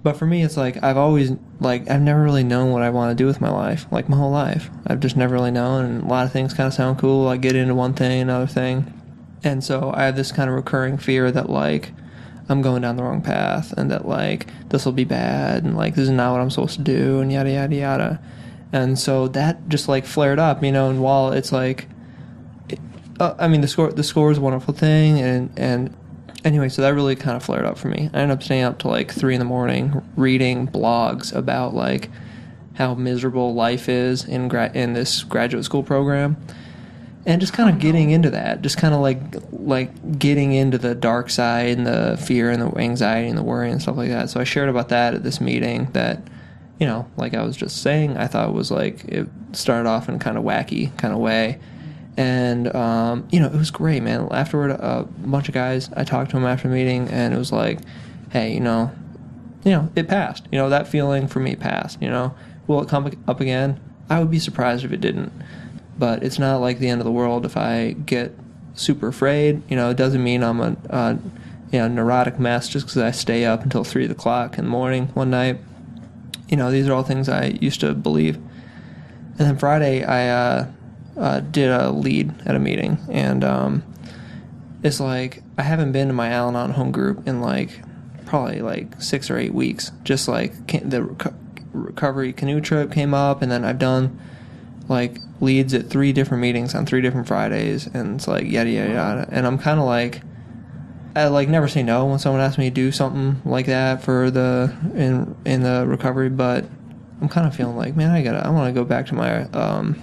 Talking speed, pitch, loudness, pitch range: 225 wpm, 130 Hz, -20 LUFS, 125-145 Hz